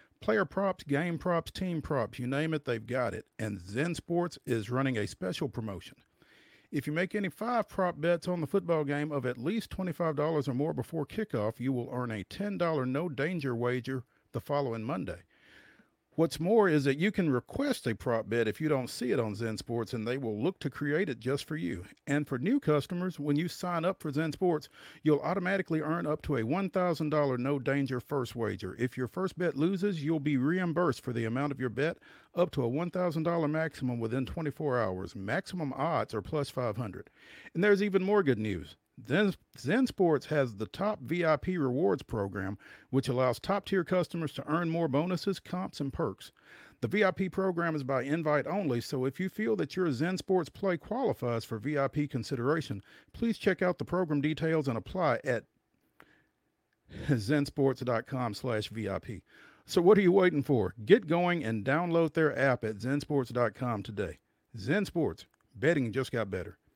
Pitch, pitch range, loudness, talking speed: 145 Hz, 125-175 Hz, -31 LUFS, 180 wpm